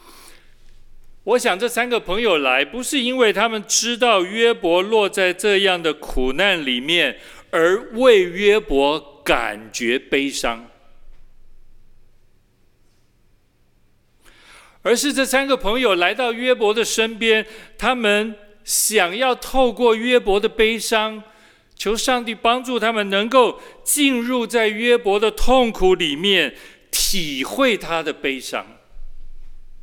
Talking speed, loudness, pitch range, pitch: 170 characters per minute, -18 LUFS, 185-245 Hz, 220 Hz